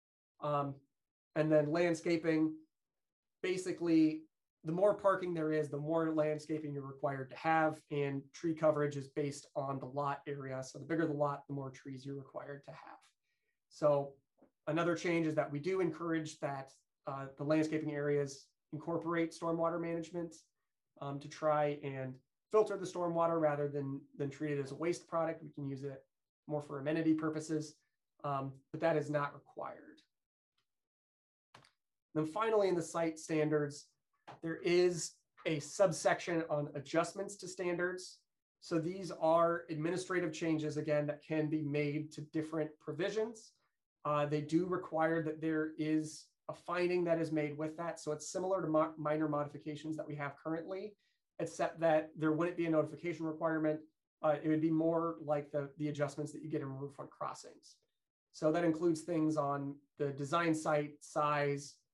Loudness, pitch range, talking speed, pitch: -37 LUFS, 145-165 Hz, 165 wpm, 155 Hz